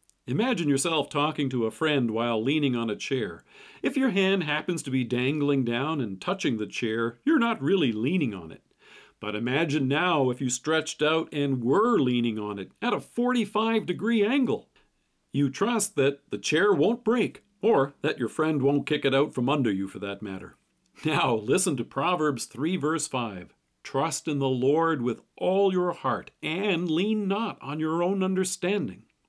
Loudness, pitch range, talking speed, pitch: -26 LUFS, 130-185 Hz, 180 wpm, 150 Hz